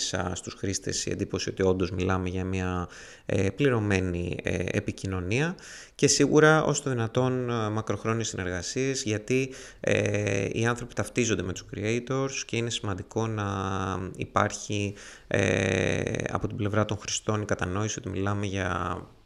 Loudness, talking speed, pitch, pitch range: -28 LUFS, 135 wpm, 105 Hz, 95-120 Hz